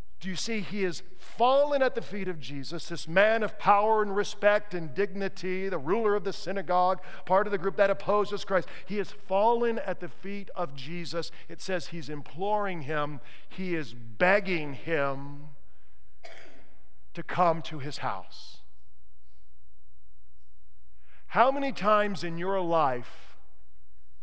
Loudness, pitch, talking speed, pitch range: -29 LUFS, 175 Hz, 145 wpm, 130-200 Hz